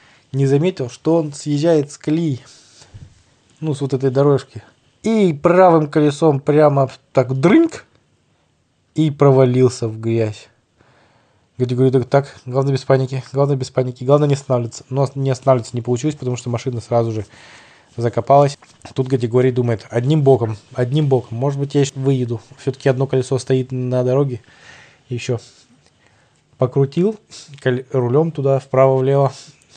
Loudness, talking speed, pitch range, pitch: -17 LUFS, 135 wpm, 125-140 Hz, 135 Hz